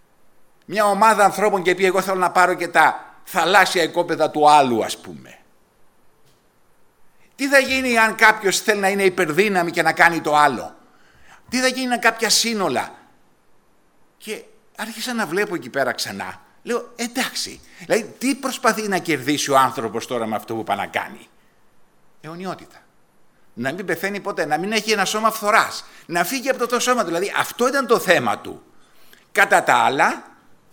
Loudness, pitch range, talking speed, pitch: -19 LUFS, 160-225 Hz, 170 wpm, 190 Hz